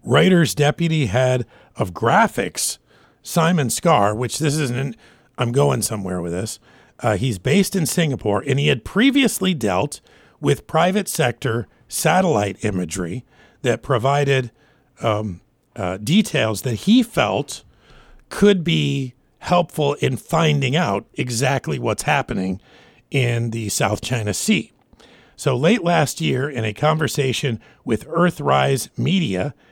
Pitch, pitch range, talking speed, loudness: 135 Hz, 115-155 Hz, 125 wpm, -20 LUFS